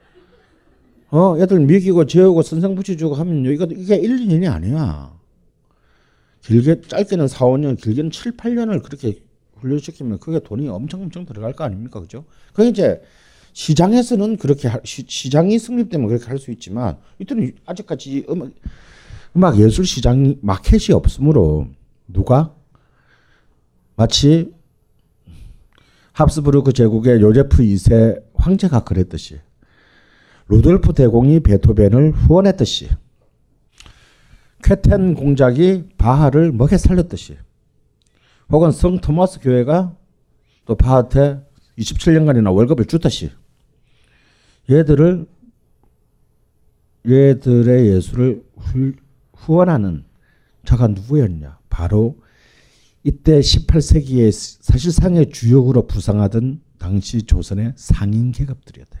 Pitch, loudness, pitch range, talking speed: 130 Hz, -15 LUFS, 110-160 Hz, 250 characters per minute